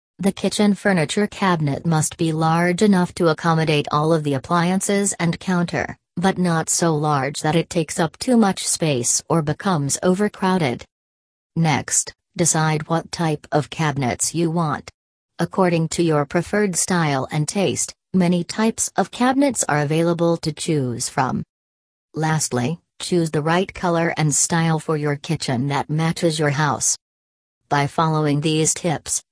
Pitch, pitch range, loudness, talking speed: 165 Hz, 150-175 Hz, -20 LUFS, 145 wpm